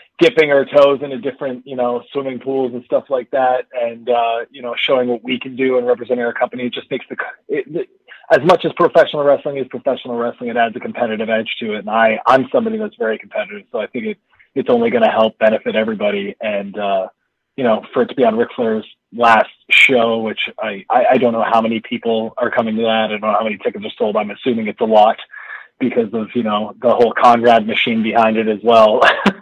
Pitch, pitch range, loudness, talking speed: 120 Hz, 110-140 Hz, -16 LUFS, 235 wpm